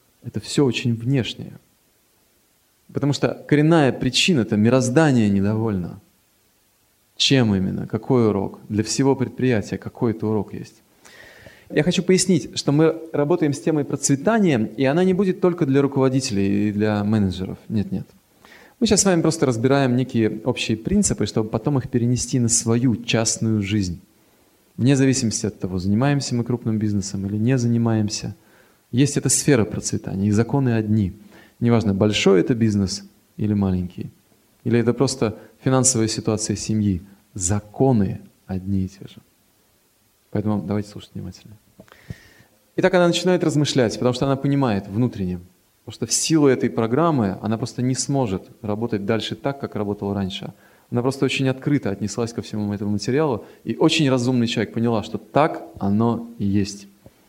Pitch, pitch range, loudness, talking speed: 115 Hz, 105-135 Hz, -21 LUFS, 150 wpm